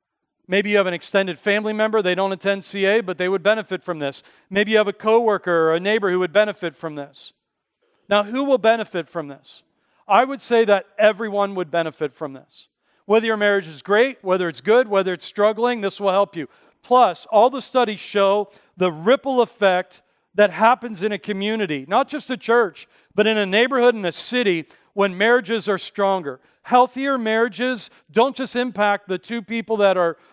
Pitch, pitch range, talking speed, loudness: 205 Hz, 185-230 Hz, 195 wpm, -20 LUFS